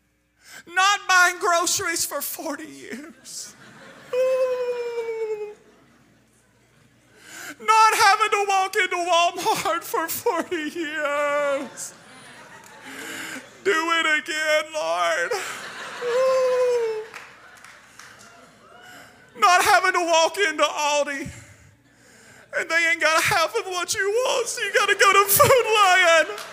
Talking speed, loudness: 95 wpm, -20 LUFS